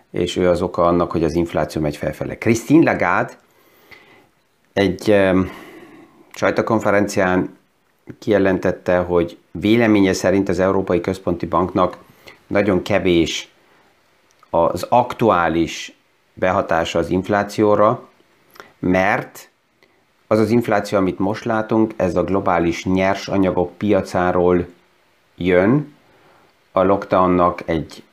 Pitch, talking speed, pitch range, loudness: 95 Hz, 100 wpm, 90-105 Hz, -18 LUFS